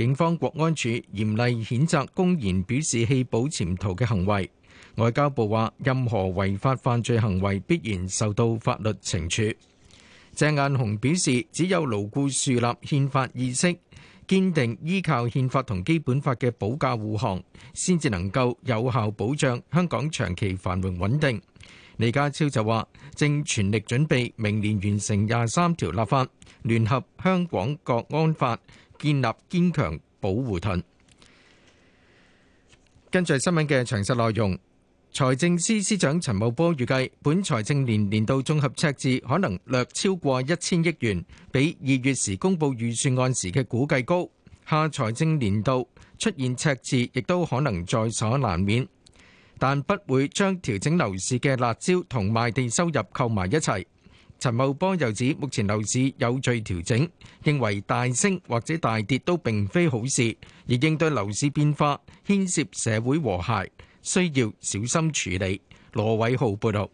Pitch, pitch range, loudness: 125 Hz, 110-150 Hz, -25 LUFS